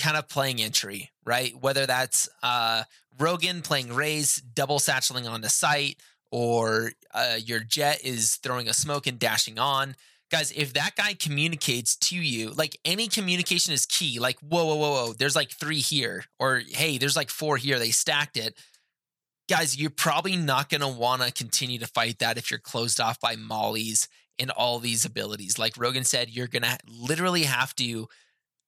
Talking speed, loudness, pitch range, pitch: 180 wpm, -25 LUFS, 120-155 Hz, 135 Hz